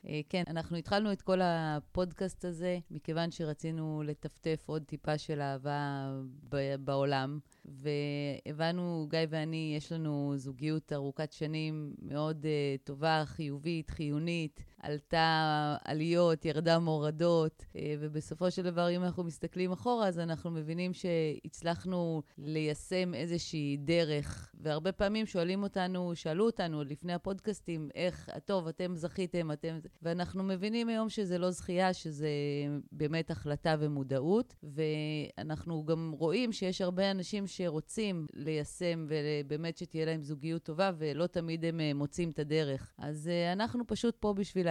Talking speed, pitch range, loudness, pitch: 130 wpm, 150-180 Hz, -35 LUFS, 160 Hz